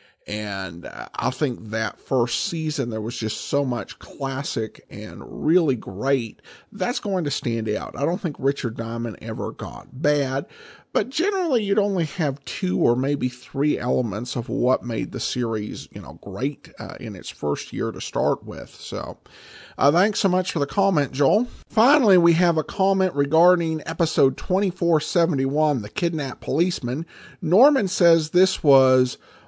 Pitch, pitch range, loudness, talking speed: 145 Hz, 125-180 Hz, -23 LUFS, 165 wpm